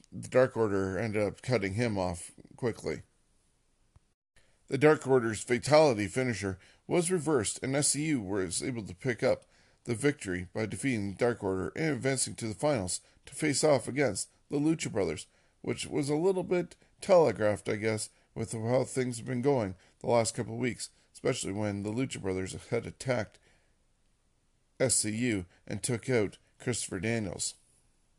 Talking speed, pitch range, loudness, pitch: 160 wpm, 100-130 Hz, -31 LUFS, 115 Hz